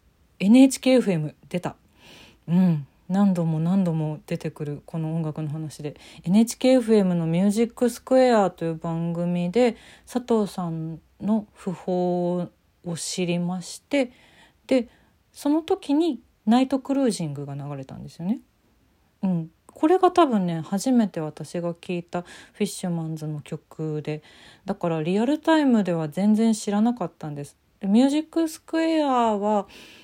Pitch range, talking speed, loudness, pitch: 165-240 Hz, 290 characters per minute, -24 LUFS, 185 Hz